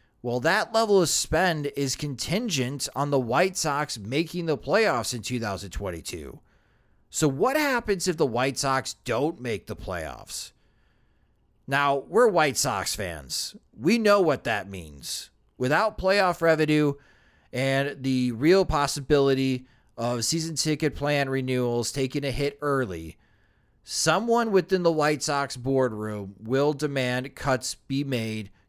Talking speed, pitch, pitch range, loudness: 135 wpm, 140 Hz, 125-155 Hz, -25 LUFS